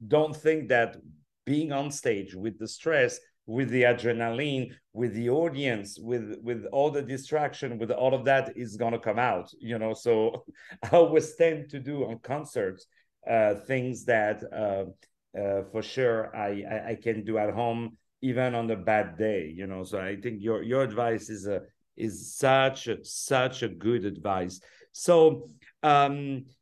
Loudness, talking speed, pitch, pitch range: -28 LUFS, 170 wpm, 120 Hz, 110-140 Hz